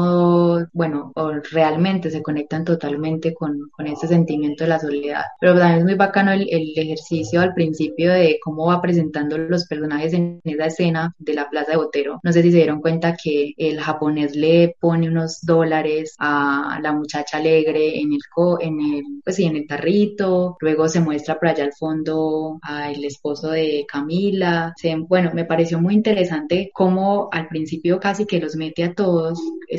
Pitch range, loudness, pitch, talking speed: 155-175 Hz, -19 LUFS, 160 Hz, 185 wpm